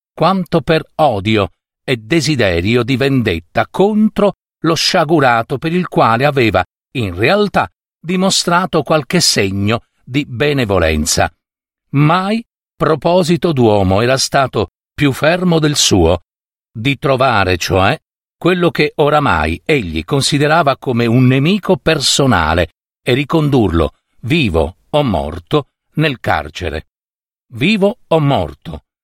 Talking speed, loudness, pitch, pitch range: 105 wpm, -14 LUFS, 145 Hz, 110-165 Hz